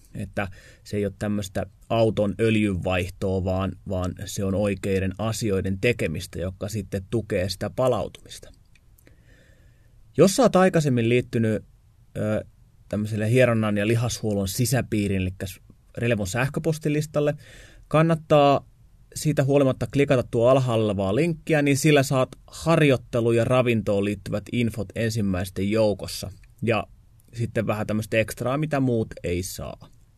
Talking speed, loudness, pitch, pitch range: 115 wpm, -24 LUFS, 110 Hz, 100-125 Hz